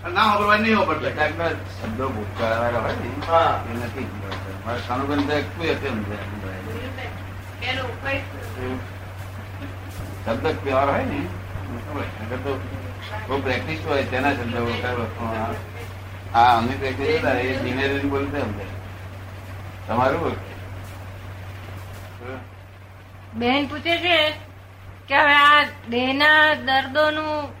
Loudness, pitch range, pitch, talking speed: -22 LUFS, 95-130 Hz, 100 Hz, 35 wpm